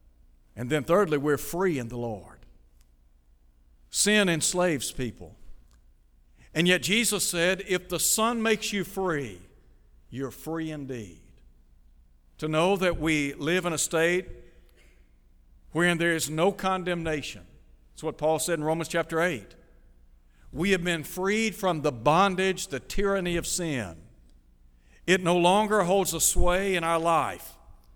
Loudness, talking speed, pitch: -26 LUFS, 140 wpm, 155 Hz